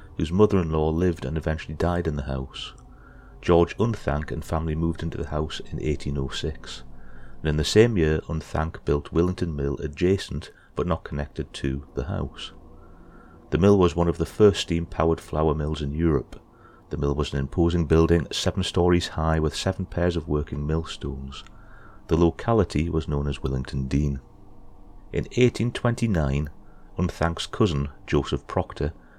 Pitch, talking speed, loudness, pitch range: 80 Hz, 160 wpm, -25 LUFS, 70-90 Hz